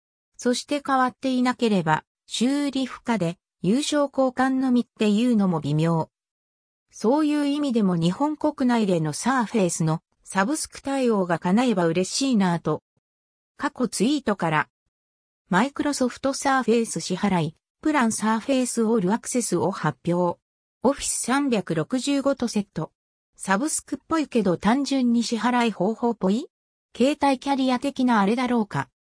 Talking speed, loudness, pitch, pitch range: 315 characters per minute, -23 LUFS, 235 Hz, 180-265 Hz